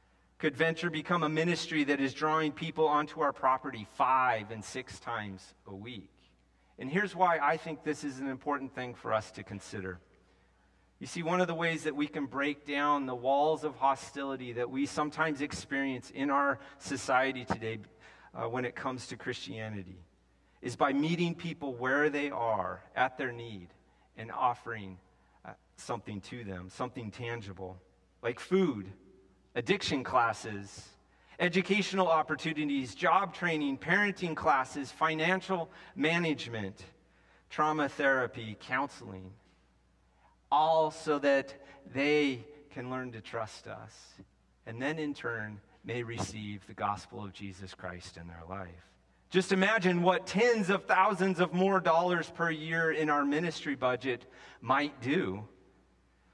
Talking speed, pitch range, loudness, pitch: 145 wpm, 95-150 Hz, -32 LUFS, 125 Hz